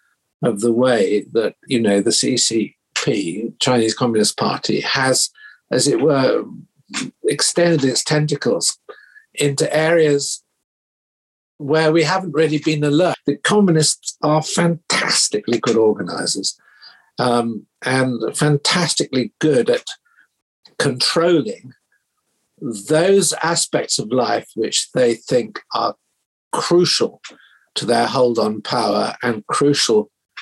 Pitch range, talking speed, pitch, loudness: 120-165 Hz, 105 wpm, 145 Hz, -17 LUFS